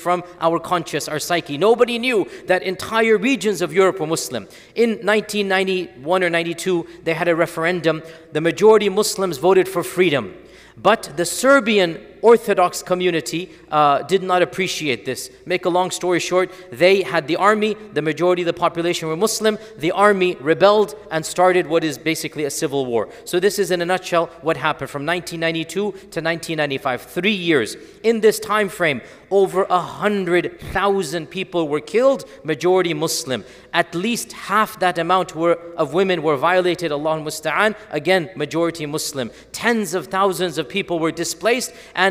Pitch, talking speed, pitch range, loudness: 180 Hz, 165 wpm, 165-195 Hz, -19 LUFS